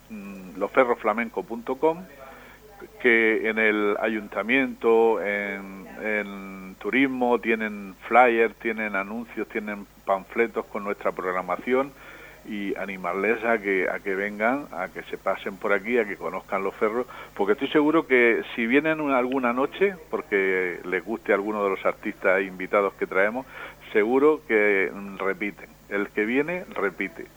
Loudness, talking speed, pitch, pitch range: -24 LUFS, 135 wpm, 110 Hz, 100-125 Hz